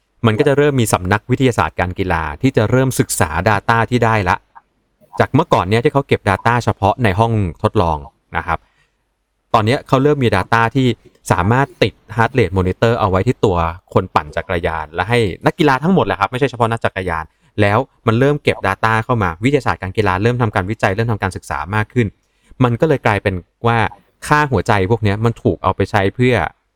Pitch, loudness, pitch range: 110 Hz, -16 LUFS, 95-120 Hz